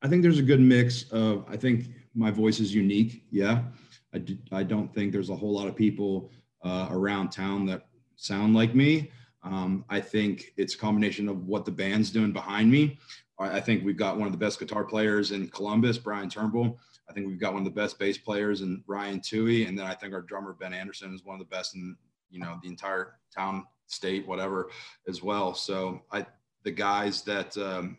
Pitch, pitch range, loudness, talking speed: 100 Hz, 95-110 Hz, -28 LUFS, 220 wpm